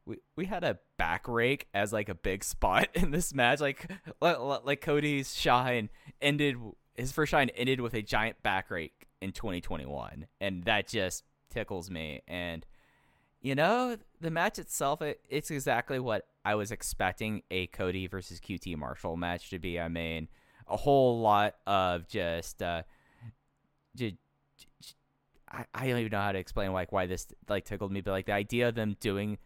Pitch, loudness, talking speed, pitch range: 105 Hz, -32 LUFS, 180 wpm, 90-135 Hz